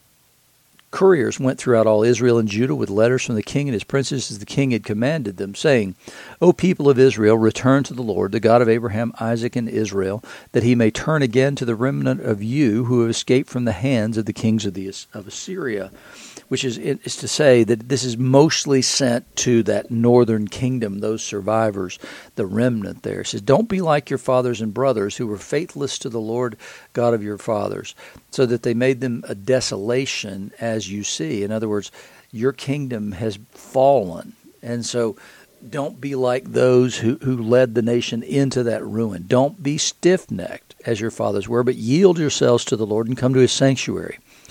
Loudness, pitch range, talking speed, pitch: -20 LUFS, 110-130 Hz, 200 wpm, 120 Hz